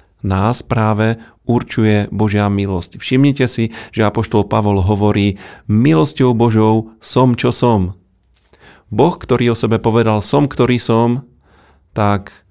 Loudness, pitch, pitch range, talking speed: -15 LUFS, 110 Hz, 100-120 Hz, 120 wpm